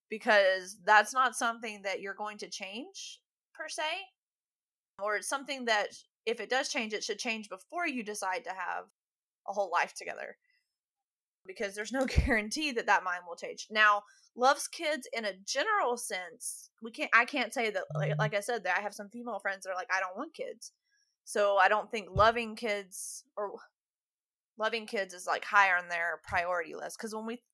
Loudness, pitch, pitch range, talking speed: -31 LUFS, 220 Hz, 200-270 Hz, 195 wpm